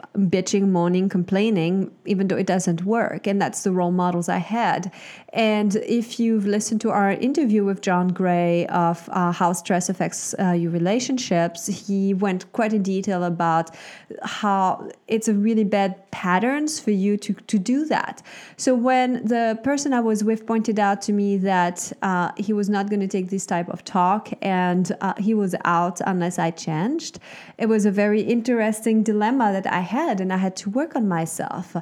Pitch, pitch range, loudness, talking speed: 200 Hz, 180-220 Hz, -22 LUFS, 185 wpm